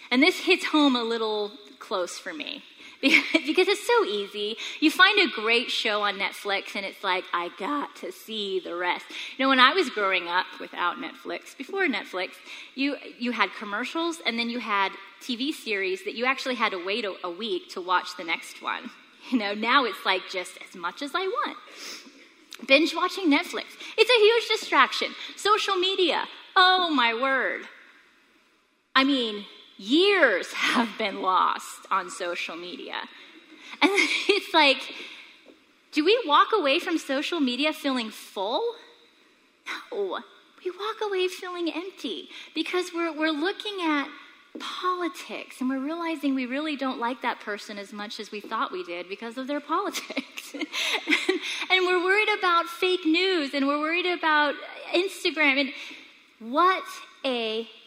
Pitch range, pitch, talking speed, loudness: 235-360 Hz, 300 Hz, 160 wpm, -25 LUFS